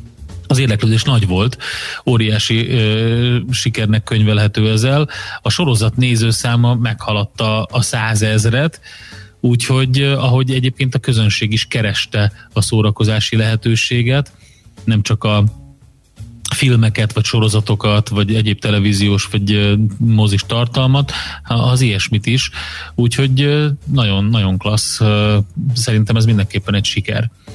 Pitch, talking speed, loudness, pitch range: 110 Hz, 105 wpm, -15 LUFS, 105-120 Hz